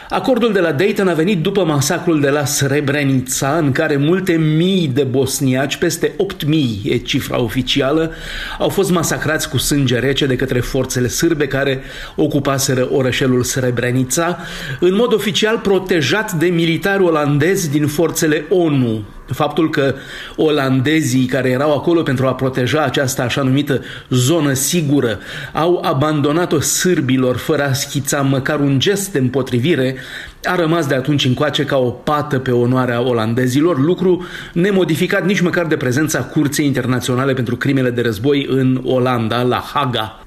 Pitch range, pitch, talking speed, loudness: 130-165 Hz, 145 Hz, 145 wpm, -16 LUFS